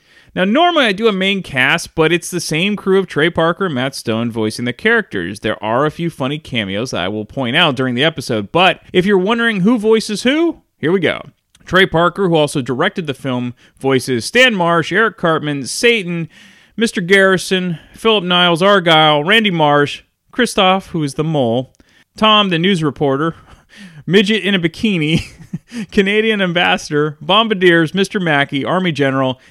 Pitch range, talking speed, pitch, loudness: 145-200 Hz, 170 wpm, 175 Hz, -14 LUFS